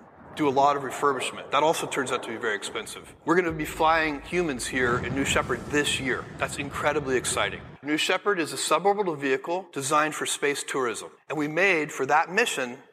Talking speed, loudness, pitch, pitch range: 205 wpm, -26 LUFS, 155 Hz, 140-185 Hz